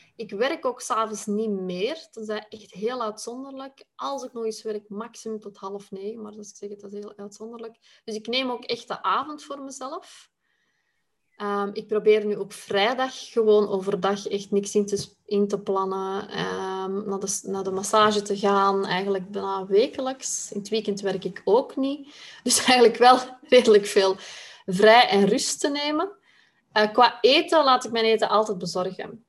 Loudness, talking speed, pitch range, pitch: -23 LUFS, 175 wpm, 200-245 Hz, 215 Hz